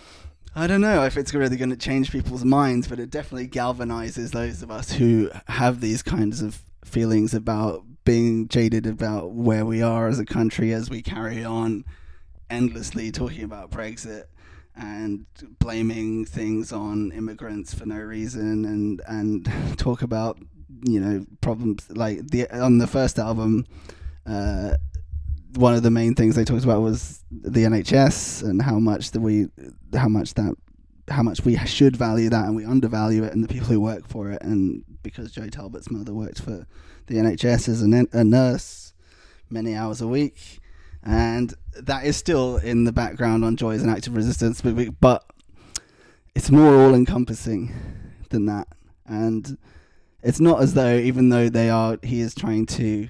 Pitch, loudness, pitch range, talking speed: 110 Hz, -22 LUFS, 105-120 Hz, 170 wpm